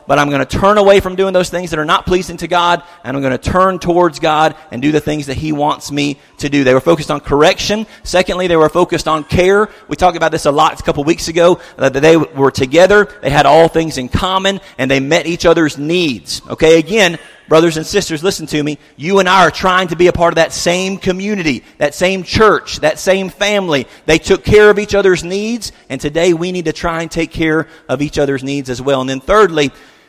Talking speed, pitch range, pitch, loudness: 245 wpm, 150-185 Hz, 165 Hz, -13 LUFS